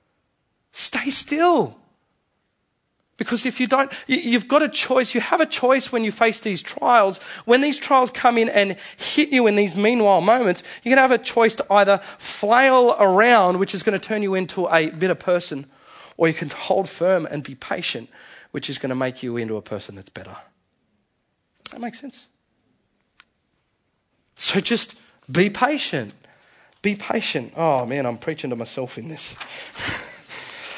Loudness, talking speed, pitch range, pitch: -20 LUFS, 165 wpm, 175-255 Hz, 215 Hz